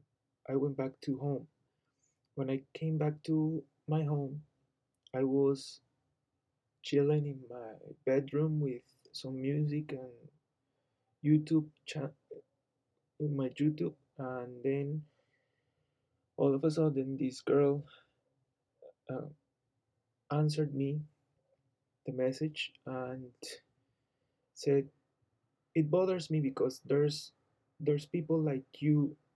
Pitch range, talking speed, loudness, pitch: 130-150 Hz, 105 wpm, -34 LUFS, 140 Hz